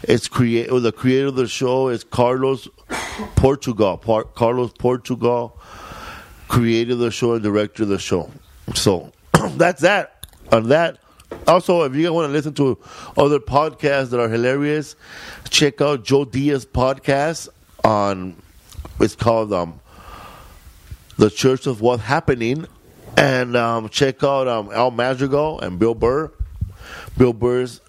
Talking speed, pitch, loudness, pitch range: 140 wpm, 125 Hz, -19 LUFS, 110-135 Hz